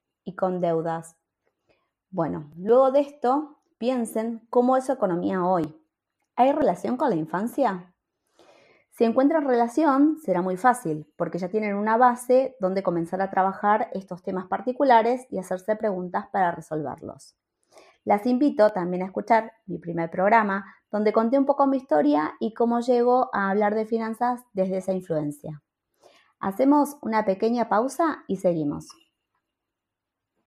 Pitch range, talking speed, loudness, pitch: 180-250 Hz, 140 wpm, -24 LUFS, 210 Hz